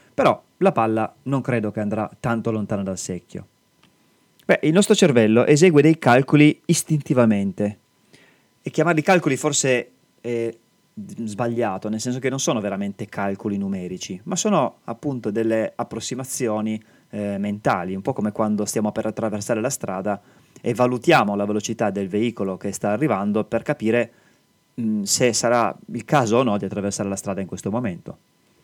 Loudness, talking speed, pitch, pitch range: -21 LUFS, 155 wpm, 115 Hz, 105-135 Hz